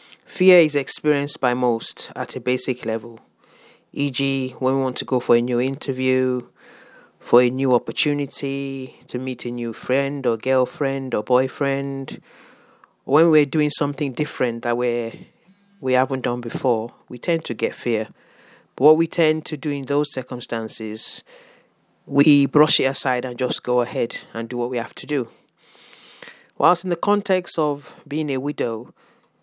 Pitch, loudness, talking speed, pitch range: 130 Hz, -21 LUFS, 165 wpm, 125-145 Hz